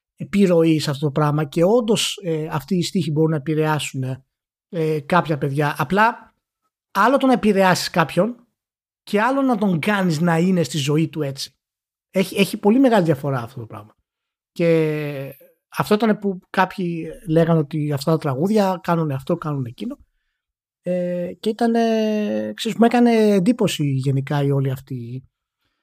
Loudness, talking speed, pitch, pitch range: -20 LUFS, 155 wpm, 170 Hz, 150-210 Hz